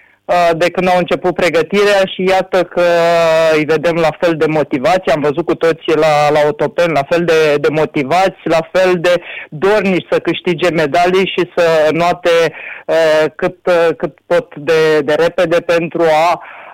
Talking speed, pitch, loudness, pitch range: 160 wpm, 170 Hz, -13 LUFS, 160-180 Hz